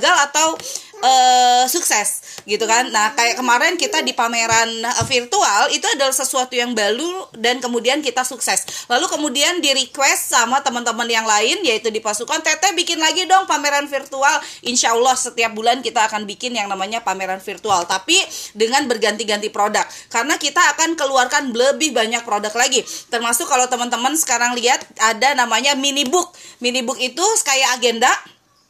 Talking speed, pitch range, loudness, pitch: 155 wpm, 230-300 Hz, -16 LUFS, 255 Hz